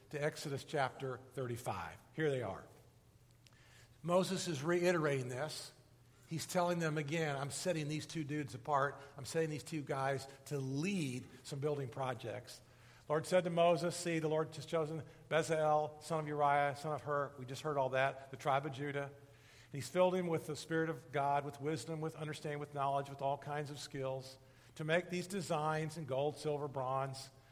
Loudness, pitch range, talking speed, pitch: -38 LUFS, 130-155 Hz, 180 wpm, 145 Hz